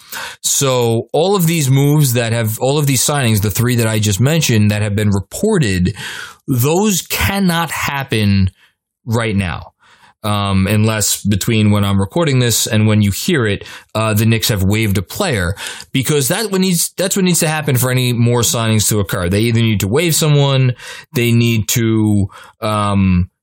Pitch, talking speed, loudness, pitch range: 115 Hz, 175 wpm, -14 LUFS, 105-145 Hz